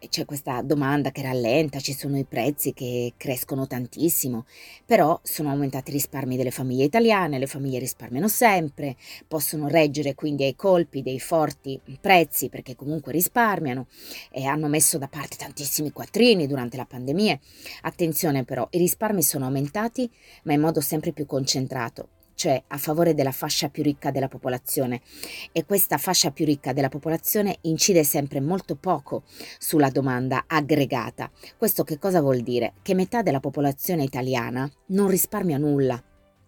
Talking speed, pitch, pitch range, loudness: 155 wpm, 145 Hz, 135-165 Hz, -24 LUFS